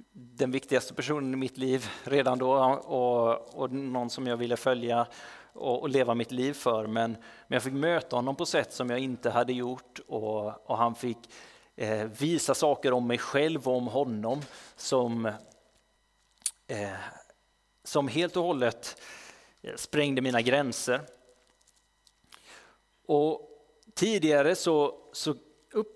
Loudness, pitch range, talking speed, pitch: -29 LUFS, 120-145 Hz, 140 wpm, 130 Hz